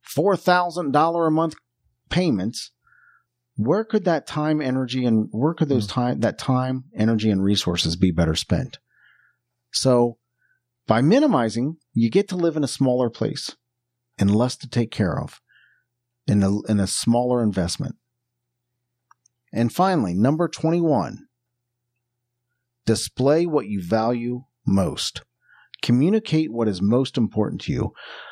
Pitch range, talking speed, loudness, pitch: 115-145 Hz, 130 wpm, -22 LUFS, 120 Hz